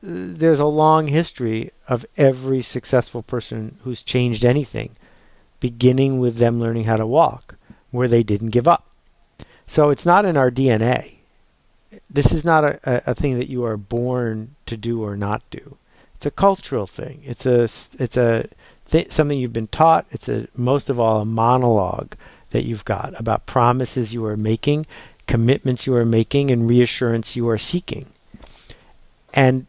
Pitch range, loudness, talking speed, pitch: 115-135 Hz, -19 LUFS, 170 wpm, 125 Hz